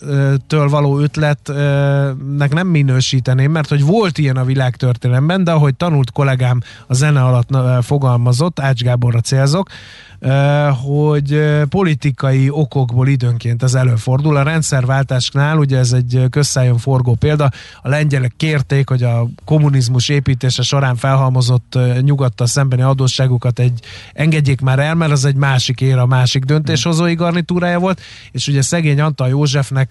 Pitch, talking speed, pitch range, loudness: 135 Hz, 135 wpm, 125-145 Hz, -14 LUFS